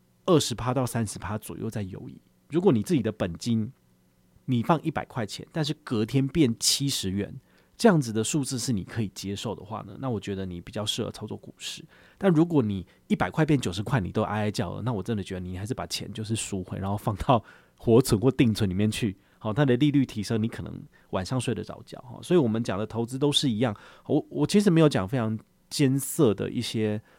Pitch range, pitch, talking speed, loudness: 100-135 Hz, 115 Hz, 330 characters per minute, -27 LUFS